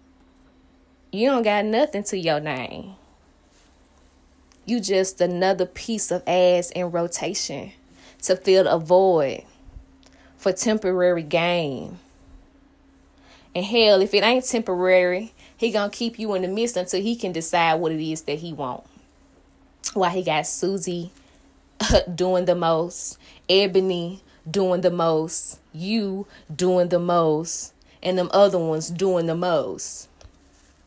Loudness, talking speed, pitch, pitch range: -22 LUFS, 130 wpm, 175 Hz, 145-190 Hz